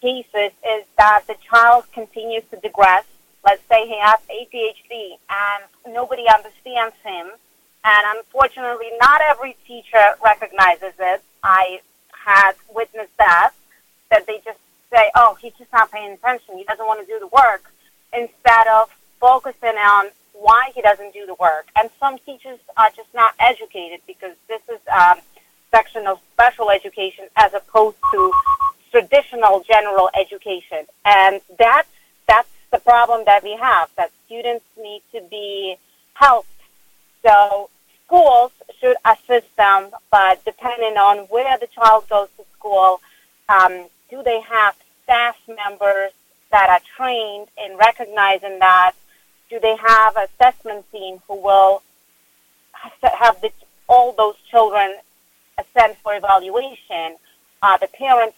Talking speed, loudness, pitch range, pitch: 140 wpm, -15 LUFS, 200-240 Hz, 220 Hz